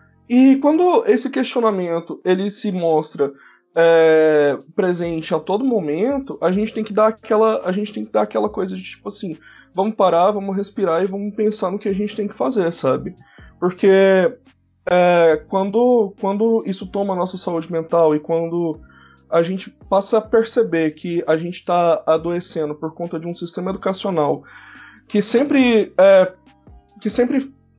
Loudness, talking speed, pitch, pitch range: -18 LUFS, 165 wpm, 190 Hz, 165-215 Hz